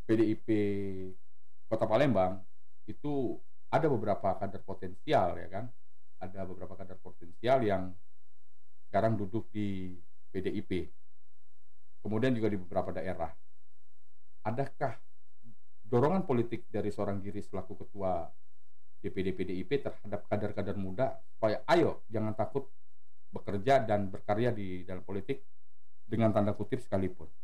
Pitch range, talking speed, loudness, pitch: 95-110 Hz, 110 wpm, -34 LUFS, 100 Hz